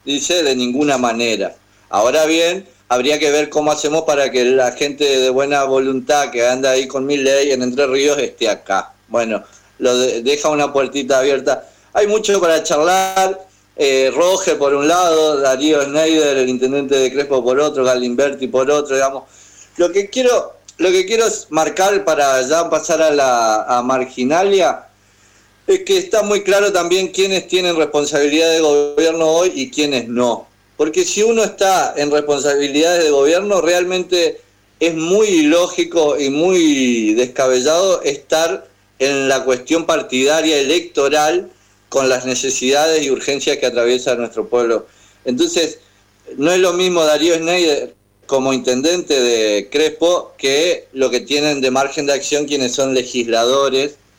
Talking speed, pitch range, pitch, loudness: 155 wpm, 130-175 Hz, 145 Hz, -15 LUFS